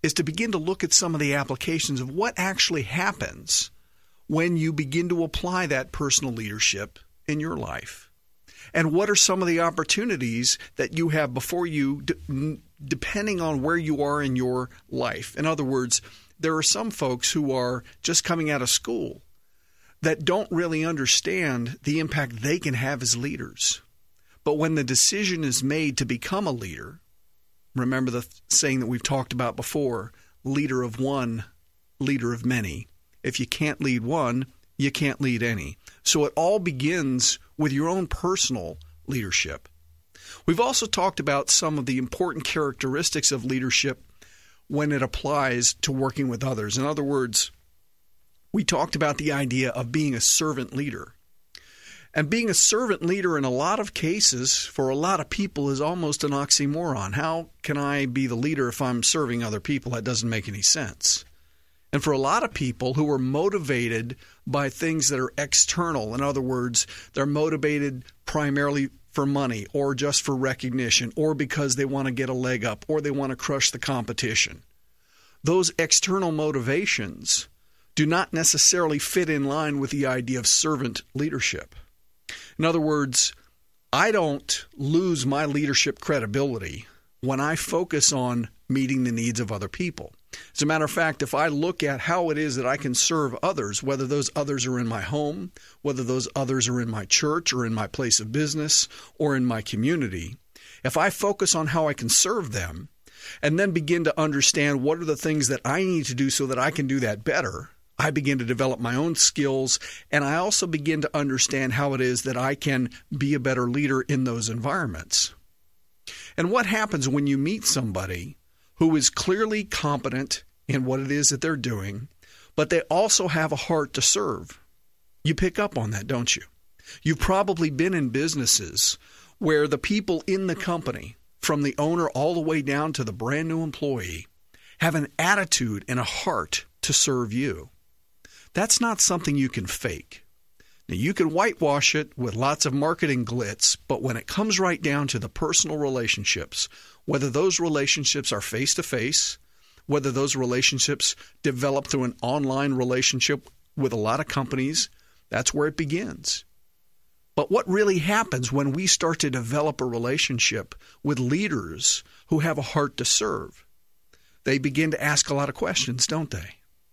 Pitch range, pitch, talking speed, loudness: 125-155 Hz, 140 Hz, 180 wpm, -24 LUFS